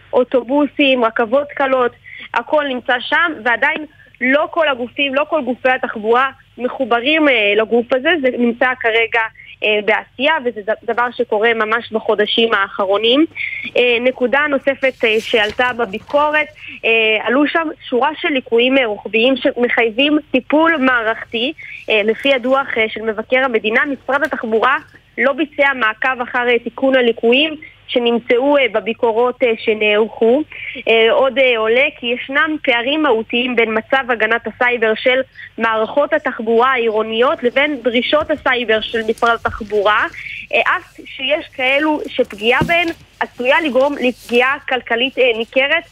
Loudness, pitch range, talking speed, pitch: -15 LUFS, 230-275 Hz, 130 wpm, 250 Hz